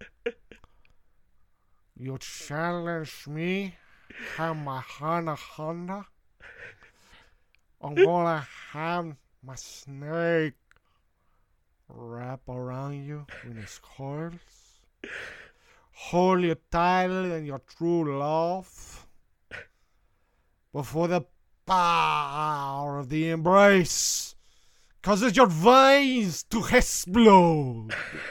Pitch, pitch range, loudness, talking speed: 160 Hz, 130-175 Hz, -24 LUFS, 75 wpm